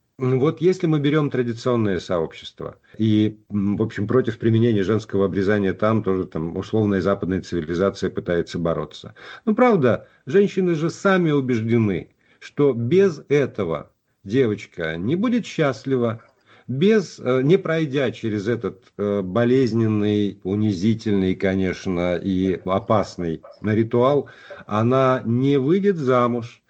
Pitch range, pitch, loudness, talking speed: 100-135 Hz, 115 Hz, -21 LUFS, 110 wpm